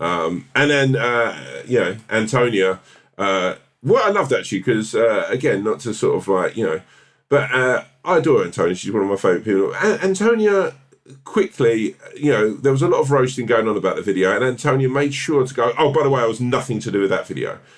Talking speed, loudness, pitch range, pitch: 230 wpm, -19 LUFS, 100-140 Hz, 125 Hz